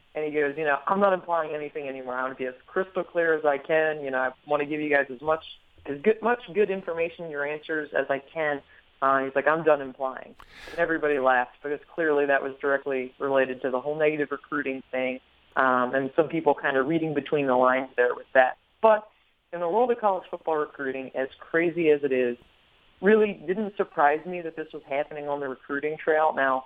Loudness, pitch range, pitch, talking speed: -26 LUFS, 135-165 Hz, 145 Hz, 225 wpm